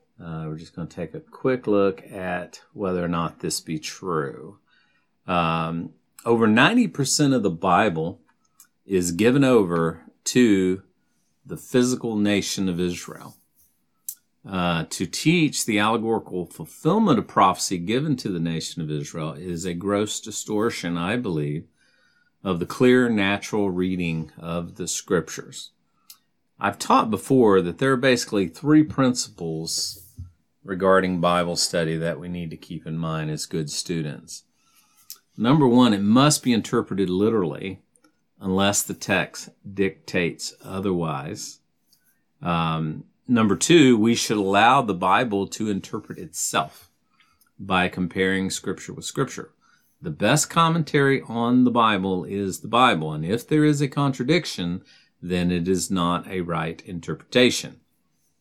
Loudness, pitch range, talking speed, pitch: -22 LUFS, 85-115 Hz, 135 wpm, 95 Hz